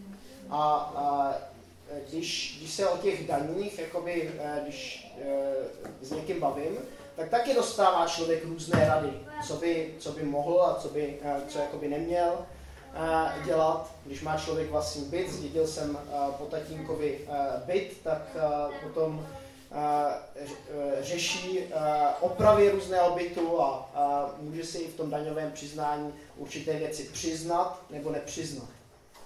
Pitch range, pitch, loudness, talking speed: 145-170 Hz, 155 Hz, -30 LUFS, 140 wpm